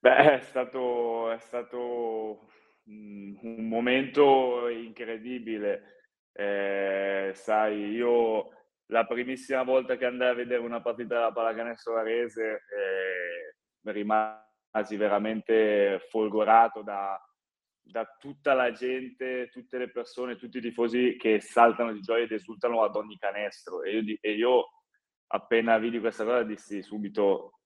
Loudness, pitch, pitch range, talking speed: -28 LUFS, 115 Hz, 110-125 Hz, 125 wpm